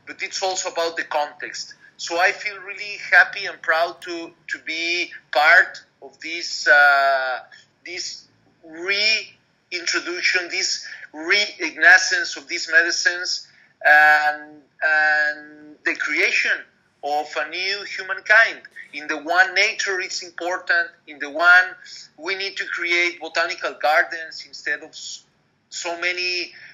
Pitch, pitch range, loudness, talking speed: 175 Hz, 150-195 Hz, -19 LUFS, 120 wpm